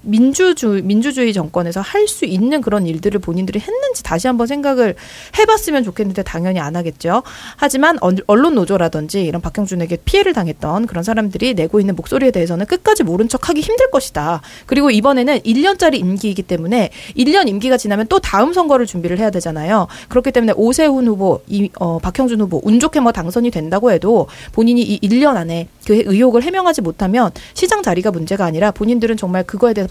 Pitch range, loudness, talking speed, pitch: 185-265 Hz, -15 LUFS, 425 characters per minute, 220 Hz